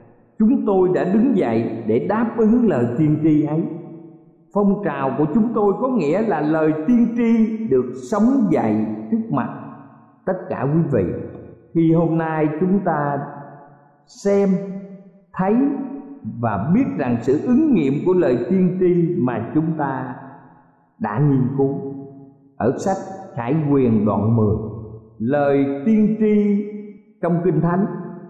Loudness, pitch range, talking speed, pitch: -19 LUFS, 140-205 Hz, 140 wpm, 165 Hz